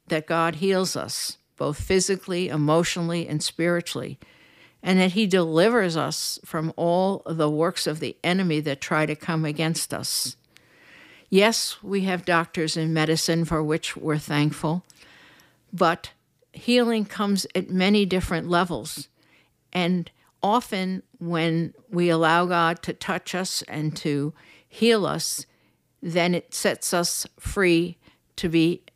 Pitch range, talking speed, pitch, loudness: 160-185 Hz, 135 wpm, 170 Hz, -24 LUFS